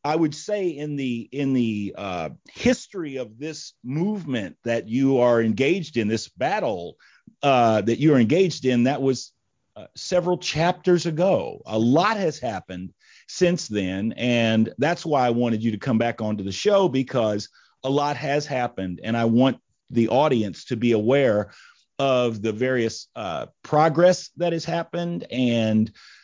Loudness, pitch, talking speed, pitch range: -23 LUFS, 130 Hz, 160 wpm, 115-160 Hz